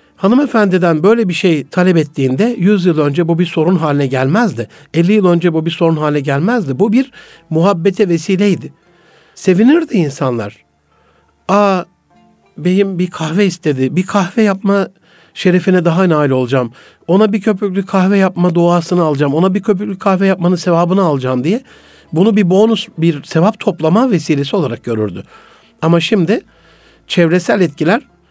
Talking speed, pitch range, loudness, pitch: 145 wpm, 160-200 Hz, -13 LUFS, 180 Hz